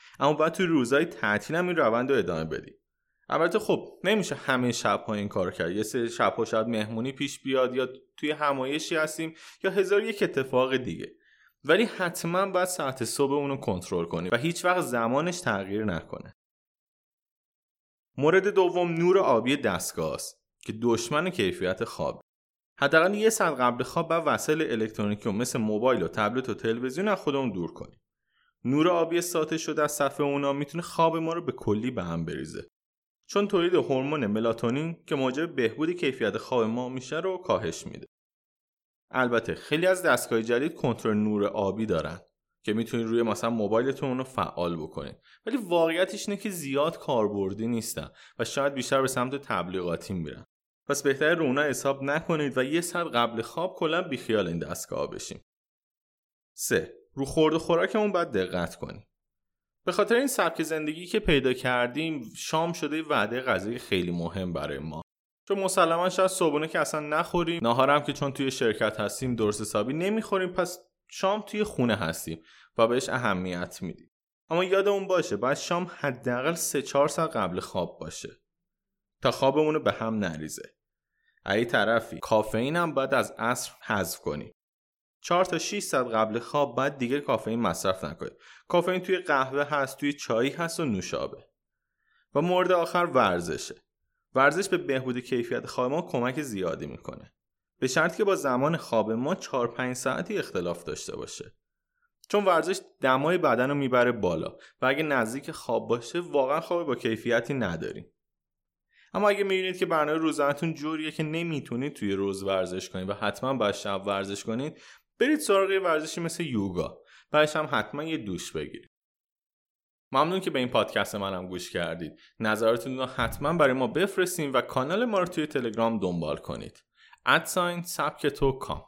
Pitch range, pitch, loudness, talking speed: 115-175 Hz, 140 Hz, -27 LUFS, 165 wpm